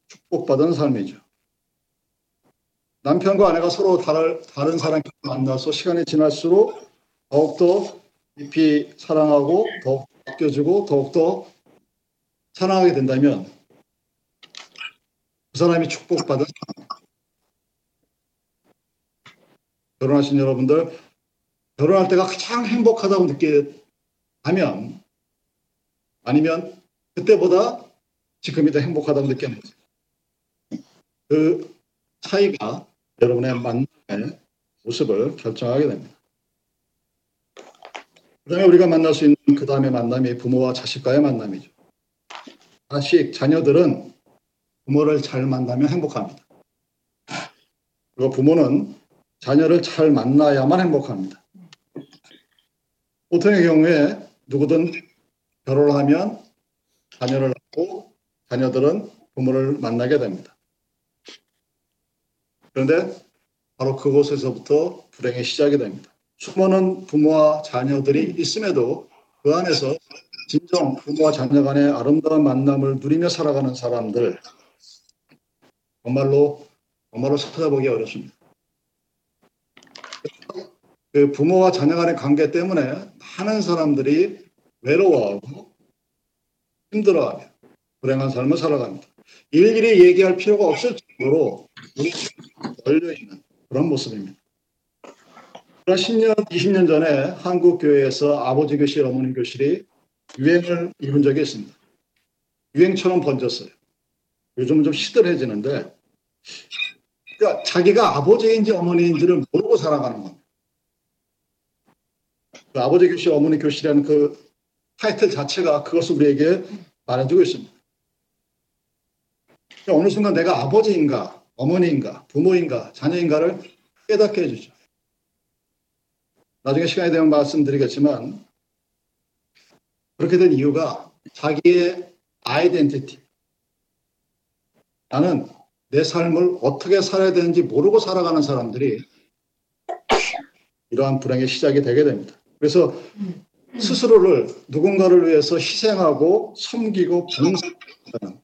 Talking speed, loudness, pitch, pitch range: 250 characters per minute, -19 LUFS, 155 Hz, 140-180 Hz